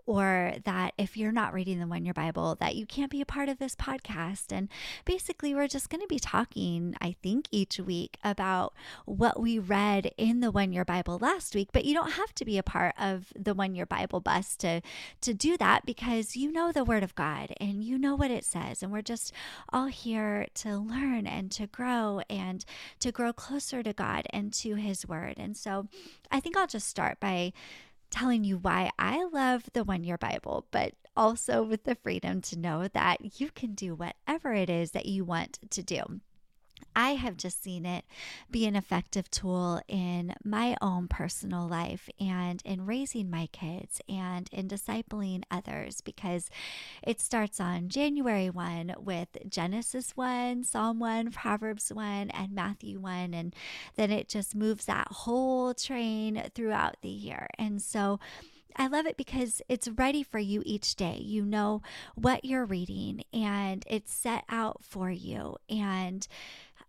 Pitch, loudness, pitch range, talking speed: 210 Hz, -32 LUFS, 185-240 Hz, 180 wpm